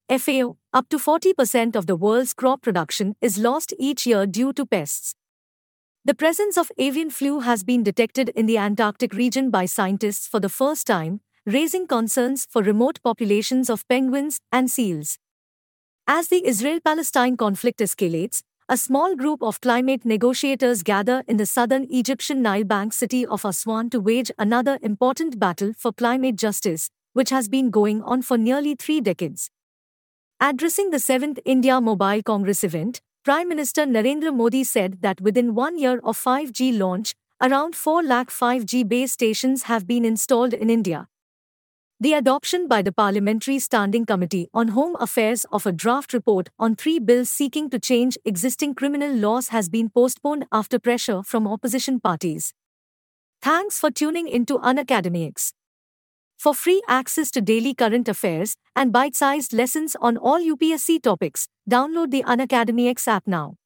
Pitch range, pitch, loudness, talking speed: 215-270 Hz, 245 Hz, -21 LUFS, 160 wpm